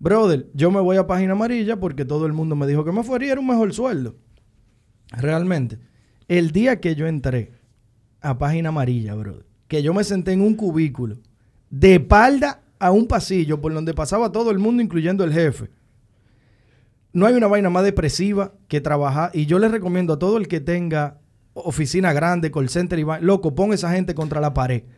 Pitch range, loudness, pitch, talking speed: 130-190 Hz, -20 LUFS, 160 Hz, 195 wpm